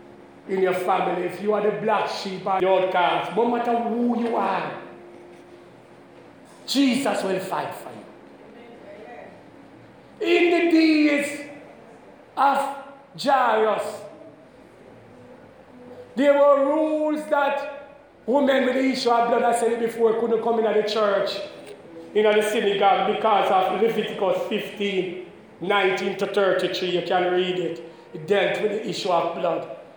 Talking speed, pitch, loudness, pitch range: 140 wpm, 215 Hz, -22 LUFS, 190-265 Hz